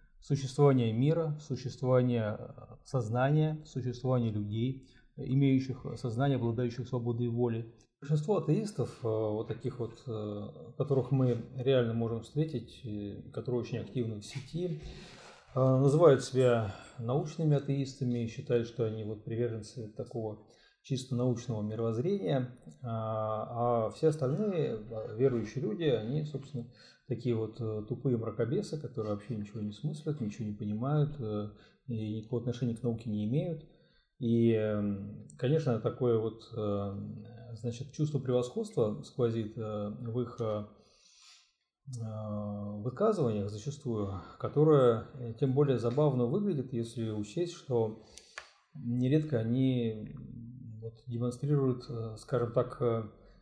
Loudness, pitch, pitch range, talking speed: -33 LUFS, 120 Hz, 110-135 Hz, 100 wpm